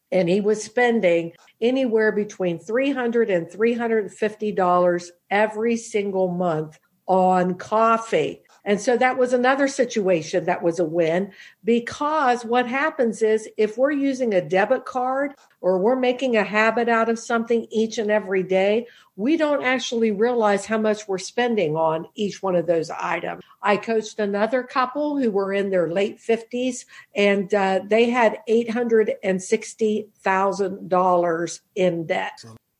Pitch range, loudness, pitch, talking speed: 185-235 Hz, -22 LUFS, 215 Hz, 145 wpm